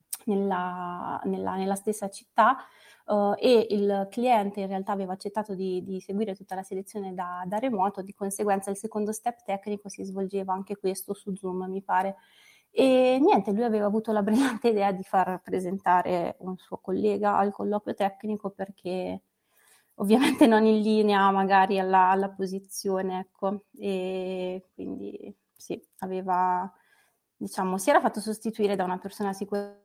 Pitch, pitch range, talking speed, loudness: 195 Hz, 190-210 Hz, 155 wpm, -27 LUFS